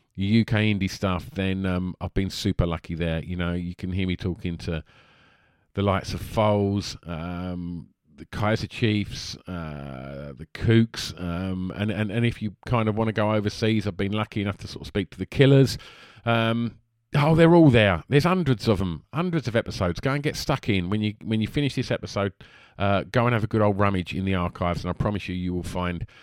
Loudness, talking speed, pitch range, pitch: -25 LUFS, 215 wpm, 90-115 Hz, 100 Hz